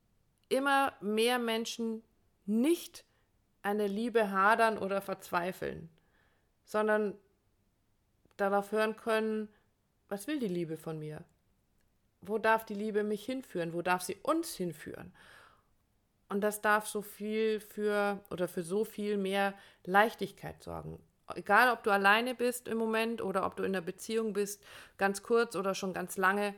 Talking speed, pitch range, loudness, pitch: 140 wpm, 180-220 Hz, -32 LUFS, 205 Hz